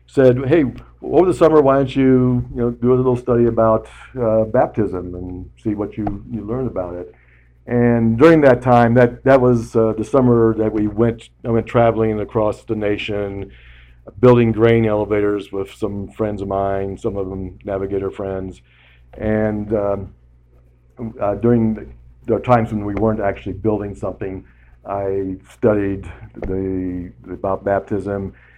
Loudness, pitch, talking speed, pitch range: -17 LUFS, 105 Hz, 160 wpm, 95-115 Hz